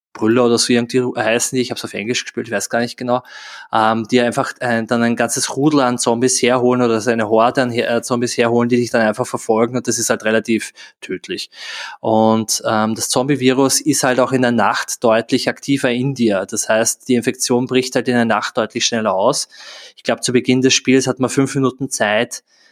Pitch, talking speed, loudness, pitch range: 120 Hz, 220 wpm, -16 LUFS, 115-130 Hz